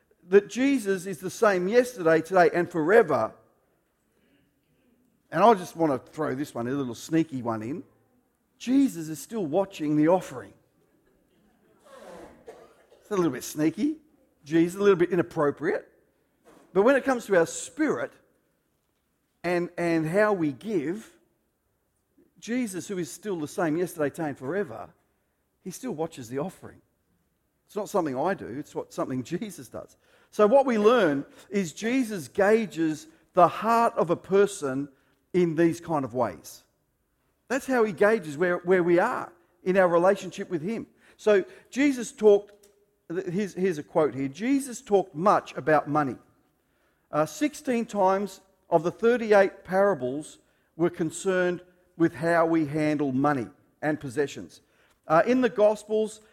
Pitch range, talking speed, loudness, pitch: 155-210 Hz, 145 wpm, -26 LUFS, 180 Hz